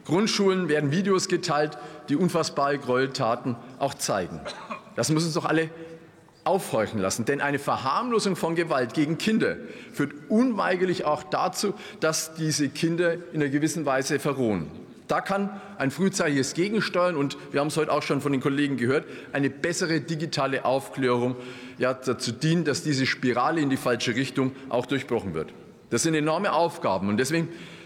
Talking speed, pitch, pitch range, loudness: 160 wpm, 150 Hz, 135-170 Hz, -26 LUFS